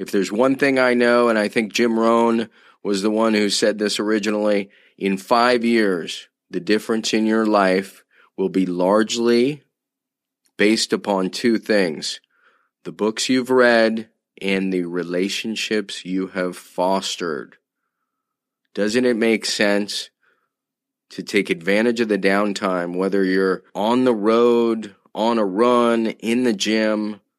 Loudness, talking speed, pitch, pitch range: -19 LUFS, 140 wpm, 105 Hz, 95-115 Hz